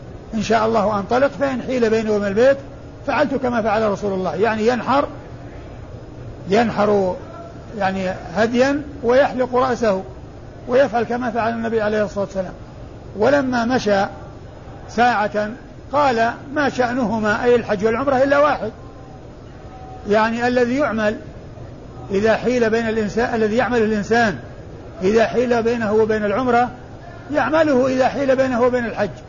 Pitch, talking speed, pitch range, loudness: 230 Hz, 125 wpm, 210-250 Hz, -18 LUFS